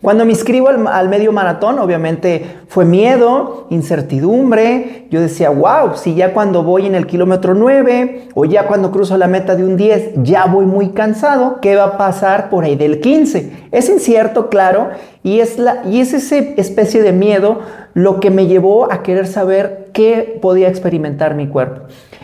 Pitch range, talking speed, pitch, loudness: 185-225 Hz, 175 wpm, 195 Hz, -12 LUFS